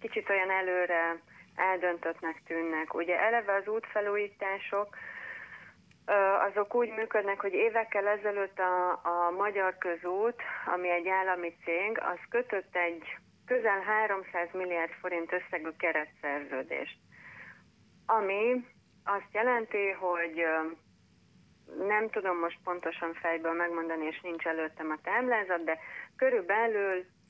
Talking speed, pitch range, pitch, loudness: 110 wpm, 170-205 Hz, 185 Hz, -31 LUFS